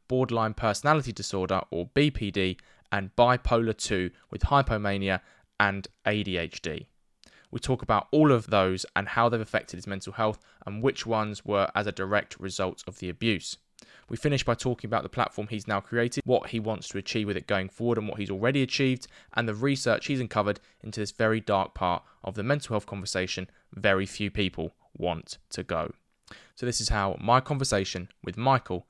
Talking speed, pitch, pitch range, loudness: 185 wpm, 105 Hz, 95-120 Hz, -28 LUFS